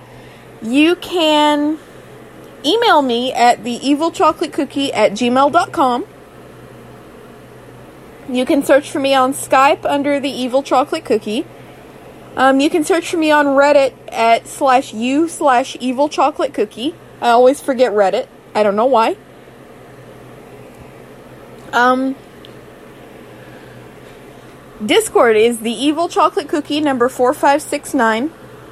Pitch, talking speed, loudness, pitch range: 275 Hz, 110 wpm, -15 LUFS, 250-305 Hz